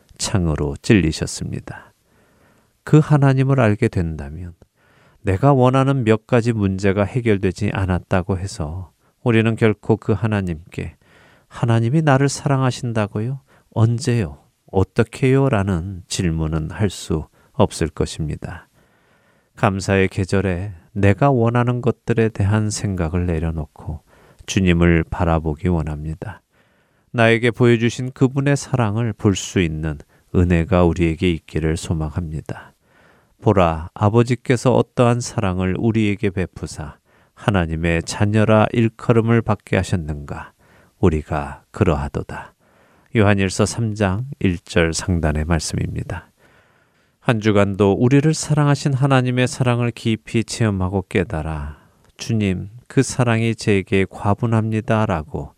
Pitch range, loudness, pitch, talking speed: 90-120 Hz, -19 LUFS, 105 Hz, 270 characters per minute